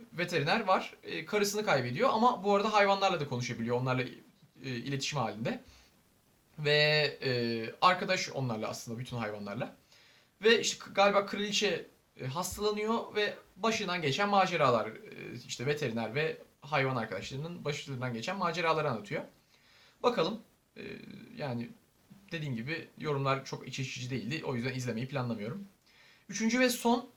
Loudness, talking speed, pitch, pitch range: -32 LUFS, 115 wpm, 150 Hz, 125-200 Hz